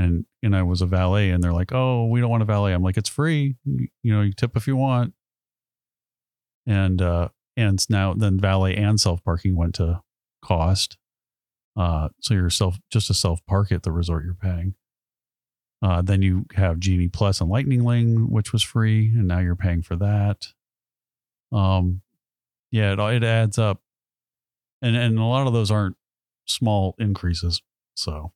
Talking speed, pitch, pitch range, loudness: 180 wpm, 100 Hz, 90-110 Hz, -22 LUFS